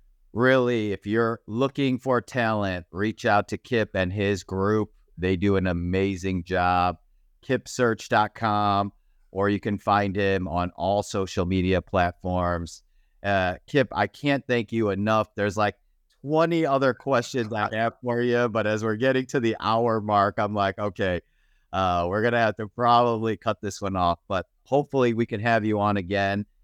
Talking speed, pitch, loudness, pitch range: 165 wpm, 105 Hz, -25 LUFS, 95-115 Hz